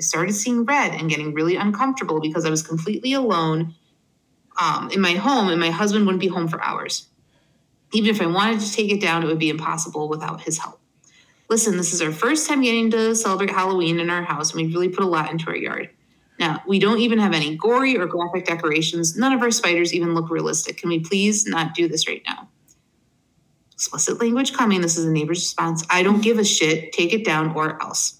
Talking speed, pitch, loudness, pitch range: 225 wpm, 175 Hz, -20 LUFS, 160-210 Hz